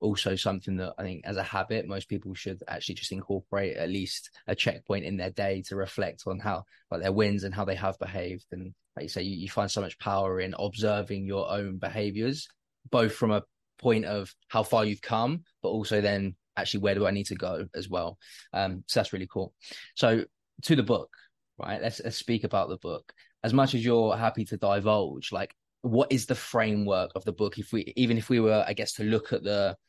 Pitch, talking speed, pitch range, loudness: 100 Hz, 225 wpm, 95-110 Hz, -30 LUFS